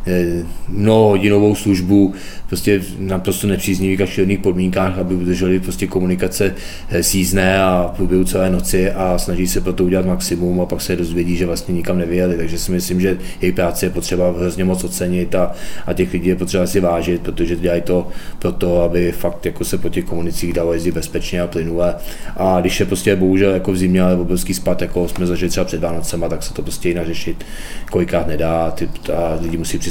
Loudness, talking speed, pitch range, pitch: -17 LUFS, 195 wpm, 85-95 Hz, 90 Hz